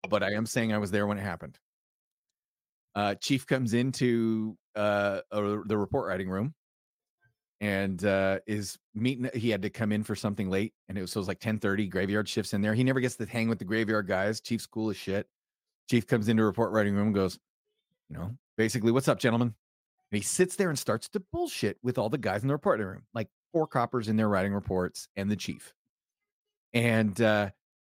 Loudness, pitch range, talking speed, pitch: -30 LUFS, 100-120 Hz, 215 wpm, 110 Hz